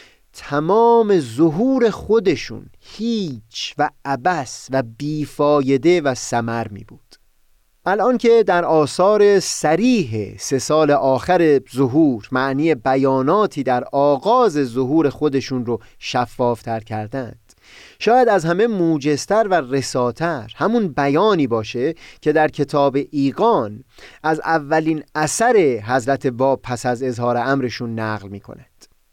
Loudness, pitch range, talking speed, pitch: -18 LUFS, 125-170 Hz, 115 wpm, 140 Hz